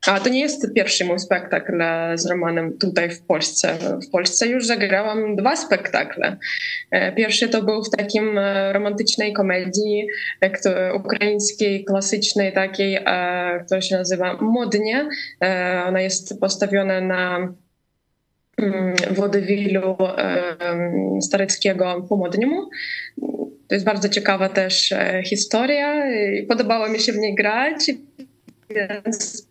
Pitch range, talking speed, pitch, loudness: 185-220 Hz, 105 wpm, 200 Hz, -20 LUFS